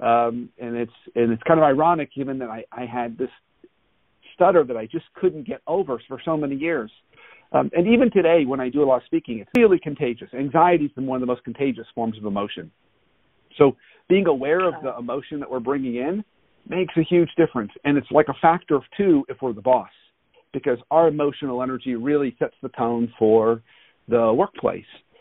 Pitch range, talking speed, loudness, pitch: 120-165 Hz, 200 wpm, -22 LUFS, 140 Hz